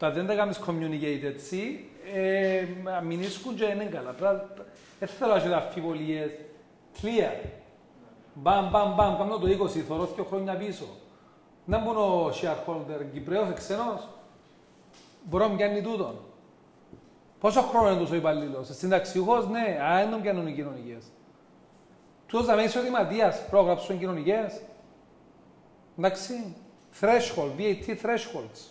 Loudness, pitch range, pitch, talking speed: -28 LUFS, 170-215 Hz, 195 Hz, 85 wpm